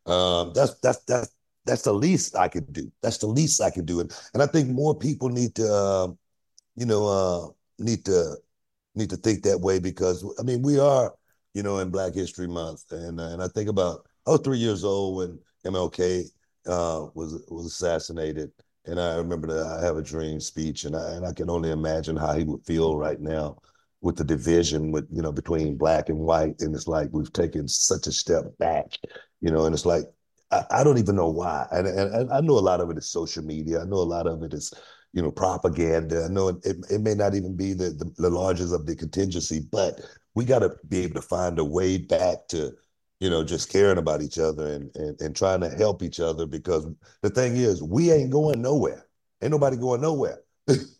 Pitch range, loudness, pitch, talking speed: 80-100 Hz, -25 LUFS, 90 Hz, 220 wpm